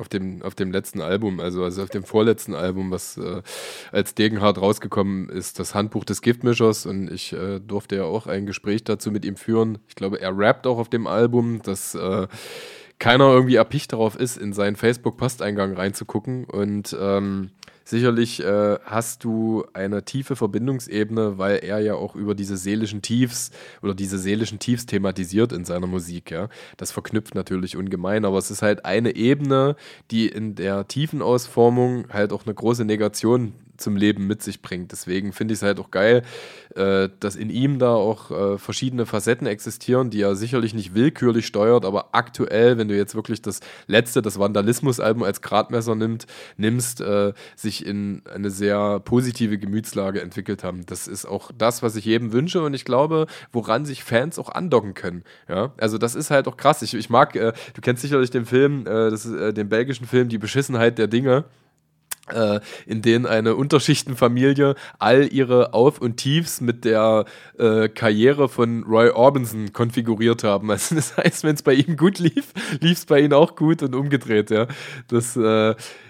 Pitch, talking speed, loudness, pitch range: 110 Hz, 180 wpm, -21 LUFS, 100-125 Hz